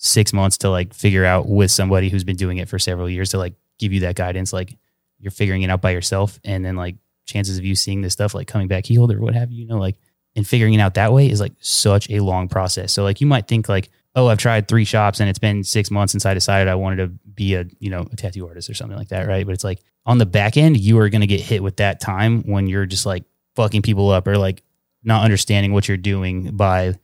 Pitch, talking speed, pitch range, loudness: 100 Hz, 275 wpm, 95-110 Hz, -18 LUFS